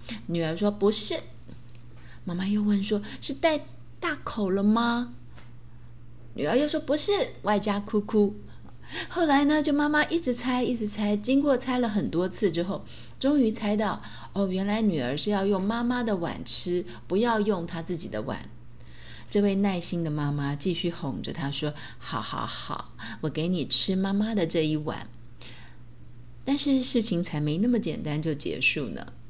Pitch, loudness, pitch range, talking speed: 195 Hz, -27 LUFS, 150-230 Hz, 230 characters per minute